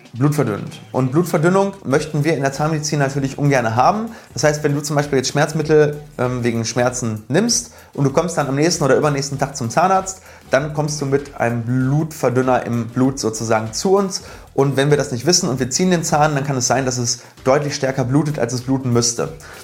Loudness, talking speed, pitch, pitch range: -18 LUFS, 210 wpm, 140 Hz, 125-155 Hz